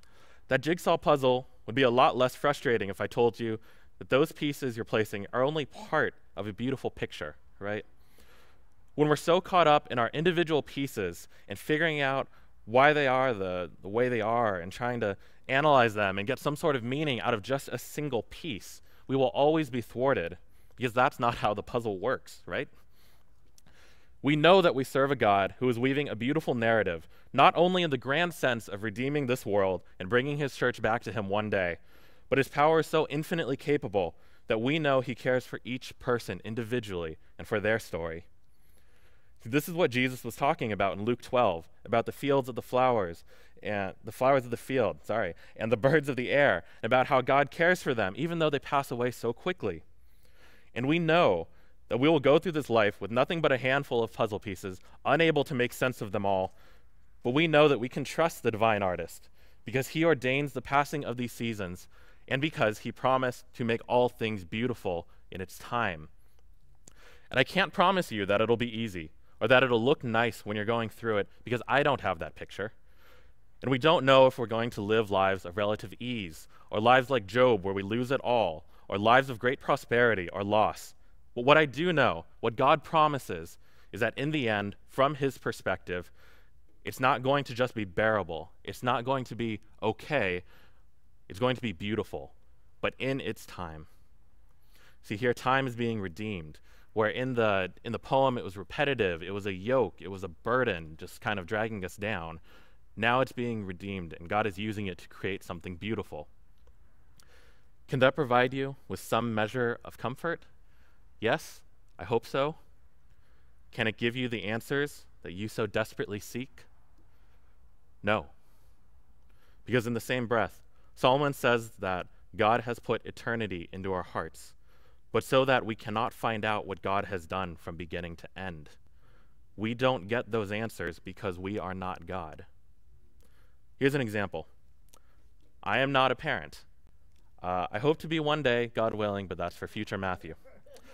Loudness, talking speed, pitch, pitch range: -29 LUFS, 190 wpm, 115 Hz, 95-130 Hz